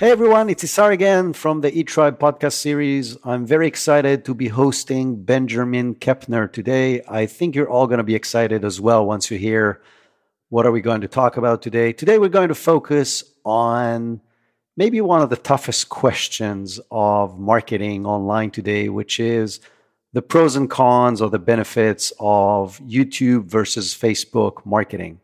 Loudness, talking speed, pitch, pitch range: -18 LUFS, 170 wpm, 120 Hz, 110-140 Hz